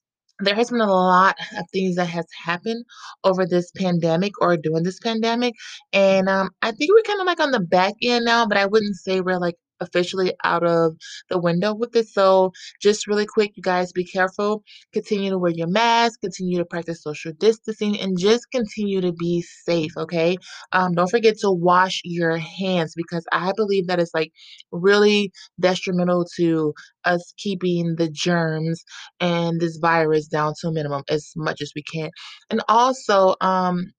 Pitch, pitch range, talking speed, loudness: 185 Hz, 170-205 Hz, 180 wpm, -21 LUFS